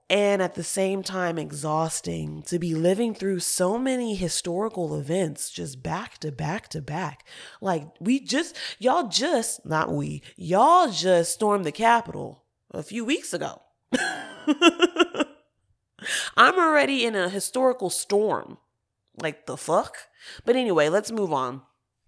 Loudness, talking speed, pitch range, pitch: -24 LUFS, 135 wpm, 160-235 Hz, 190 Hz